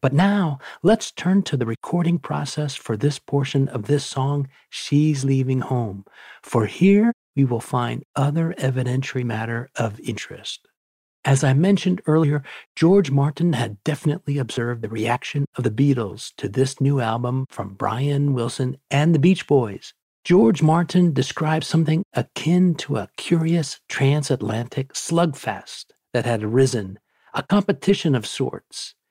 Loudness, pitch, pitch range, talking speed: -21 LUFS, 140 Hz, 125-160 Hz, 140 wpm